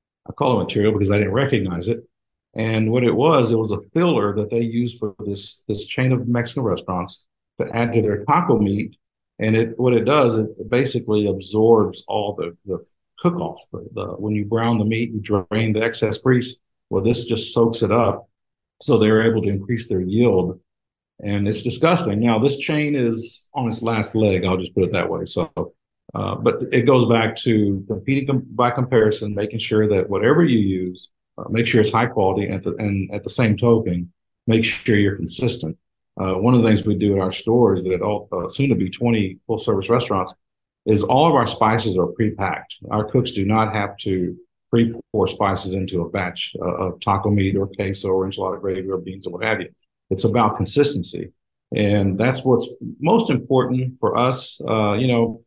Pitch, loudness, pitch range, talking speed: 110 Hz, -20 LUFS, 100-120 Hz, 200 wpm